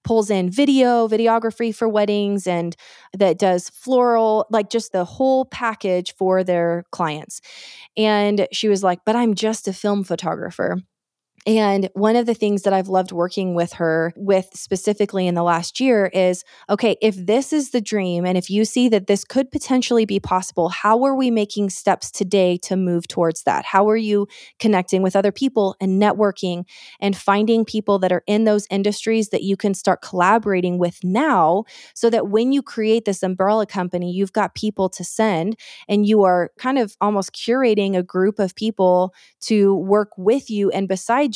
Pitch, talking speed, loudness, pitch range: 205 Hz, 185 wpm, -19 LUFS, 185-220 Hz